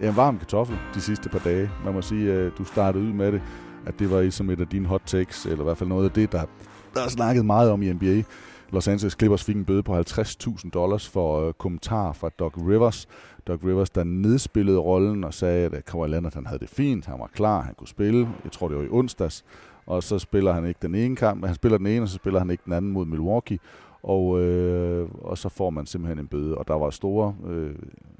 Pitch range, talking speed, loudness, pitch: 85-105 Hz, 245 wpm, -25 LUFS, 95 Hz